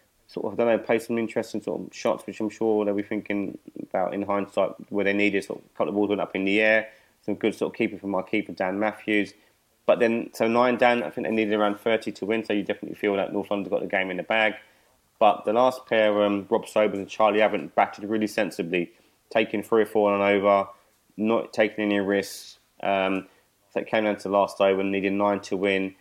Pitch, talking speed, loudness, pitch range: 105 Hz, 250 wpm, -25 LUFS, 100-110 Hz